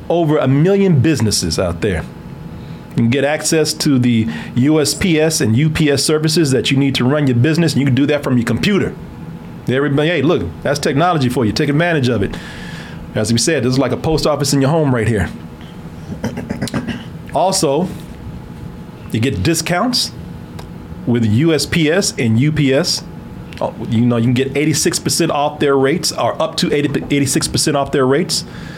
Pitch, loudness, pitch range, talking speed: 140 Hz, -15 LUFS, 125-155 Hz, 170 wpm